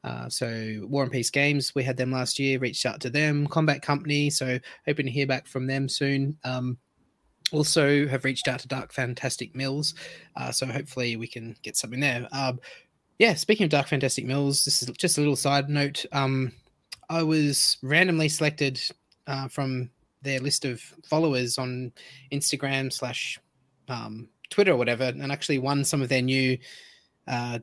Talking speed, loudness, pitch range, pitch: 180 wpm, -26 LUFS, 125-145 Hz, 135 Hz